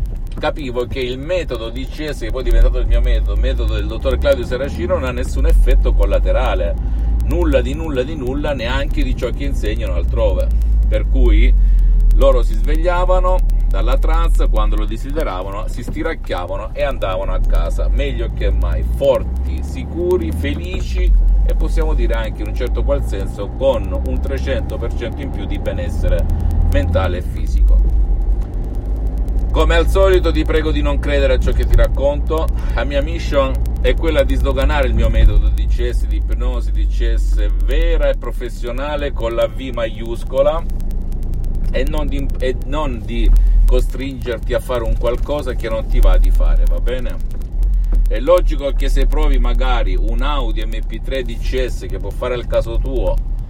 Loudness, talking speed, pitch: -19 LUFS, 165 wpm, 110 Hz